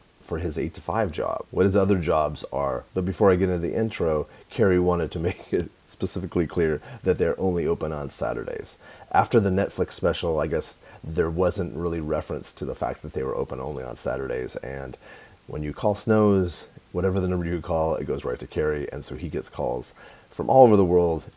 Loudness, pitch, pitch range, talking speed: -25 LUFS, 90 Hz, 80-95 Hz, 215 wpm